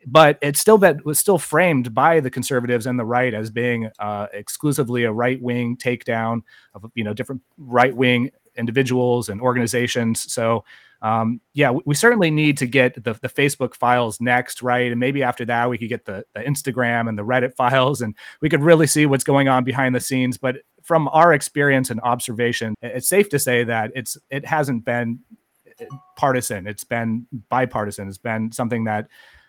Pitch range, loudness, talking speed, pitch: 120-140 Hz, -19 LUFS, 190 wpm, 125 Hz